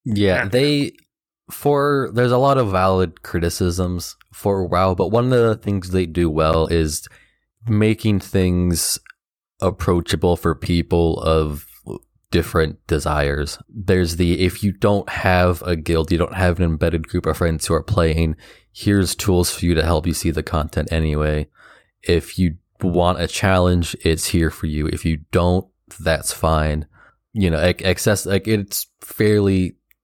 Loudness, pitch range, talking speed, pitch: -19 LUFS, 80-100 Hz, 155 wpm, 90 Hz